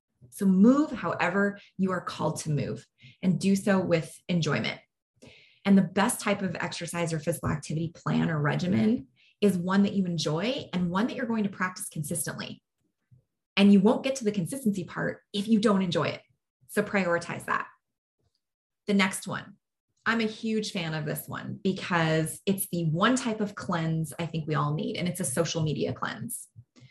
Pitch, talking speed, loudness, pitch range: 180 Hz, 185 wpm, -28 LUFS, 160-205 Hz